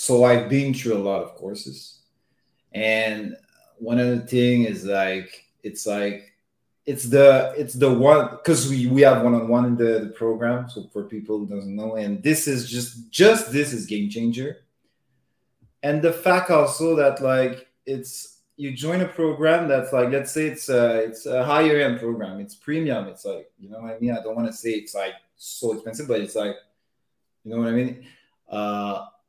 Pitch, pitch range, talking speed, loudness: 125 Hz, 110-145 Hz, 195 wpm, -21 LUFS